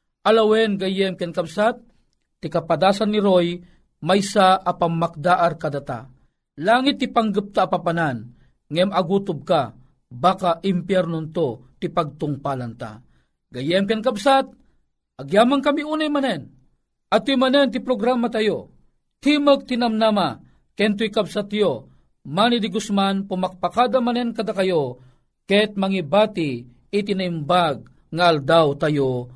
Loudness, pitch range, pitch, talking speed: -20 LUFS, 165-220 Hz, 190 Hz, 110 wpm